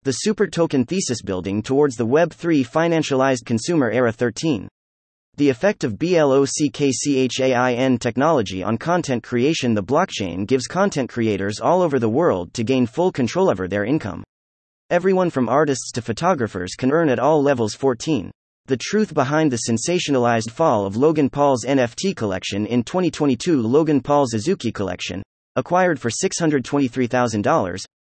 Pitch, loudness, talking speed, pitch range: 130 Hz, -20 LUFS, 145 wpm, 115-155 Hz